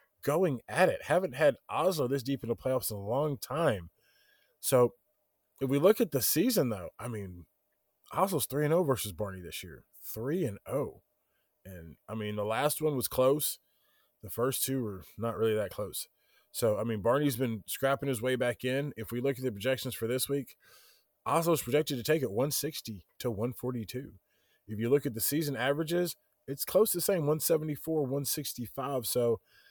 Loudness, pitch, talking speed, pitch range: -31 LUFS, 130 Hz, 190 wpm, 115-145 Hz